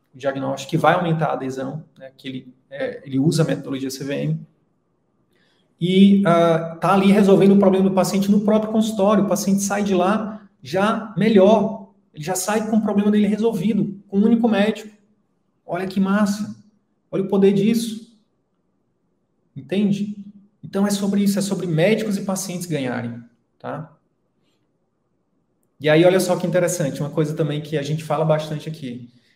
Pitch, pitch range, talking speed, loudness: 190 Hz, 155-205 Hz, 165 wpm, -19 LUFS